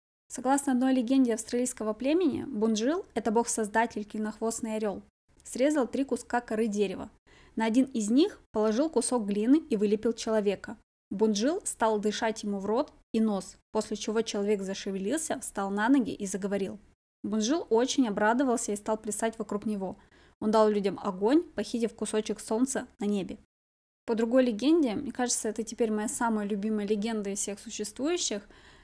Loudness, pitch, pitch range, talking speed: -29 LUFS, 225 Hz, 210-250 Hz, 150 wpm